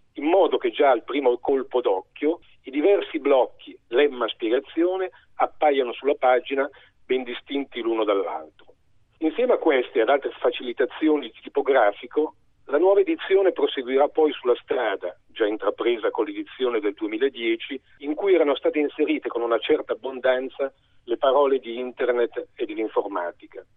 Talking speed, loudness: 140 wpm, -23 LUFS